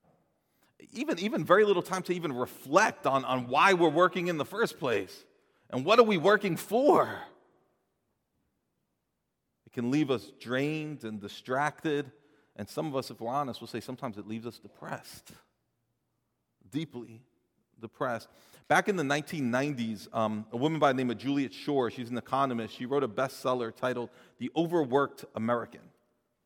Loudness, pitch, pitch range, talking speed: -29 LUFS, 135 Hz, 120-155 Hz, 160 wpm